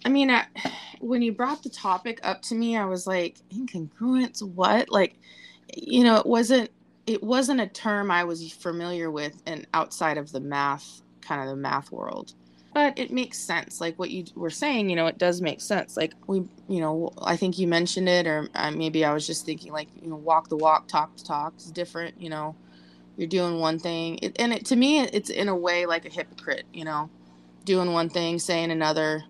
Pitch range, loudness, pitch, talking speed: 155-215 Hz, -26 LUFS, 175 Hz, 215 wpm